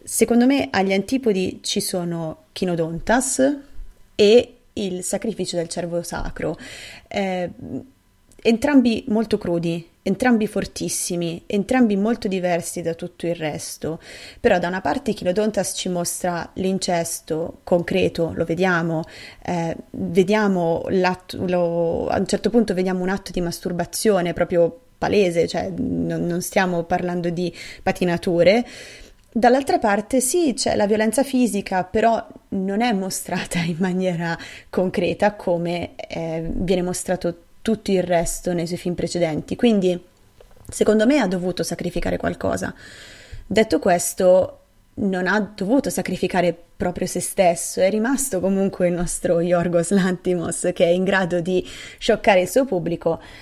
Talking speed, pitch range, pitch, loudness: 130 wpm, 170-210 Hz, 185 Hz, -21 LUFS